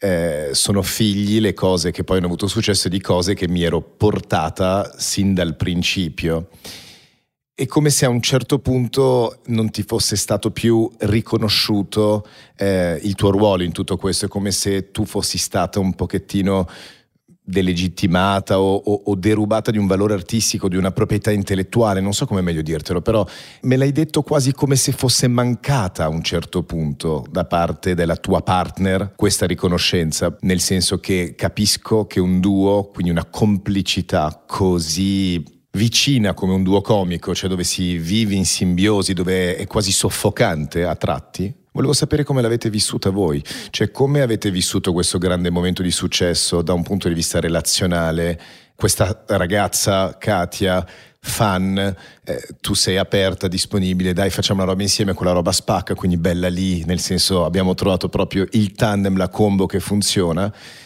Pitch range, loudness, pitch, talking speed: 90-105 Hz, -18 LUFS, 95 Hz, 165 wpm